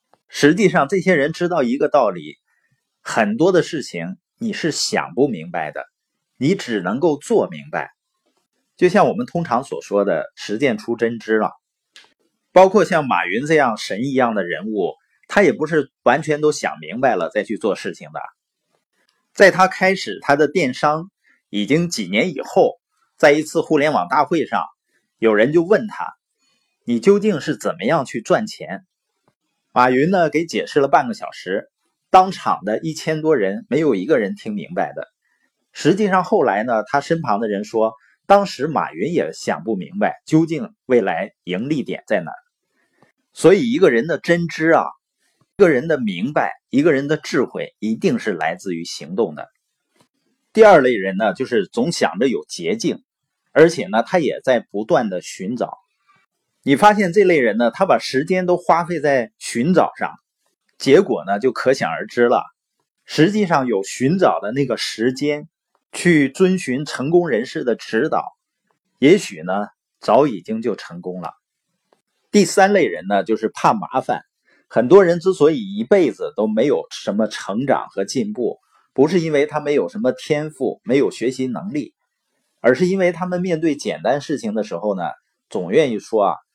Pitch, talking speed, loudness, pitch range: 160 Hz, 245 characters per minute, -18 LUFS, 135-195 Hz